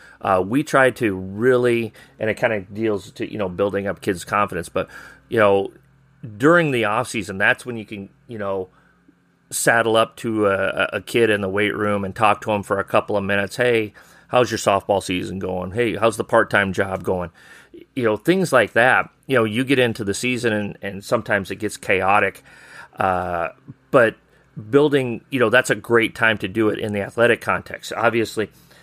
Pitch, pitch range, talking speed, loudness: 110 Hz, 100-125 Hz, 200 wpm, -20 LUFS